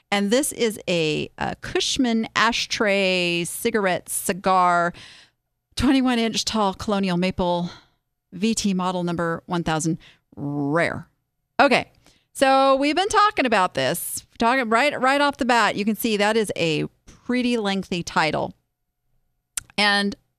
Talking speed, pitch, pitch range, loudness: 130 wpm, 200 Hz, 170-235 Hz, -21 LUFS